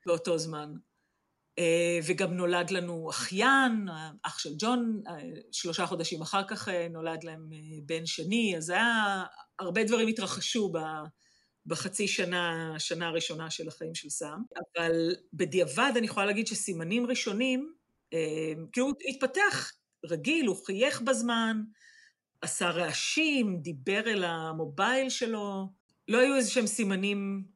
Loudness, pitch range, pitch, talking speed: -30 LUFS, 165-225 Hz, 190 Hz, 125 wpm